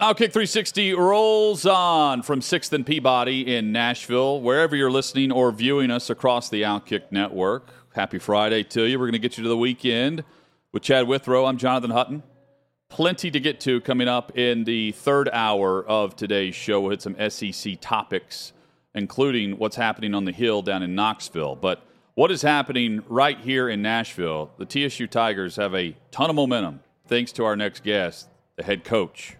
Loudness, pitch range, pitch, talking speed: -22 LUFS, 105-140 Hz, 120 Hz, 180 wpm